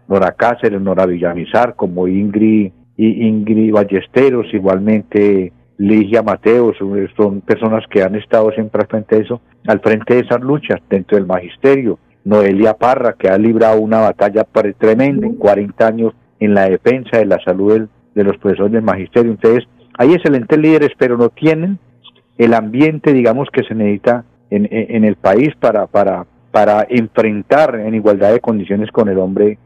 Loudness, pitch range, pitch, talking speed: -13 LUFS, 100-120 Hz, 110 Hz, 165 wpm